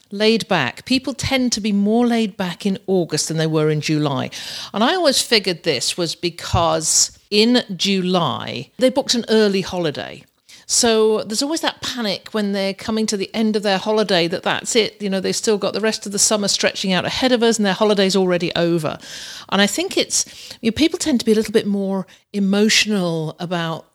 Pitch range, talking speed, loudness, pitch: 180-220 Hz, 210 wpm, -18 LUFS, 200 Hz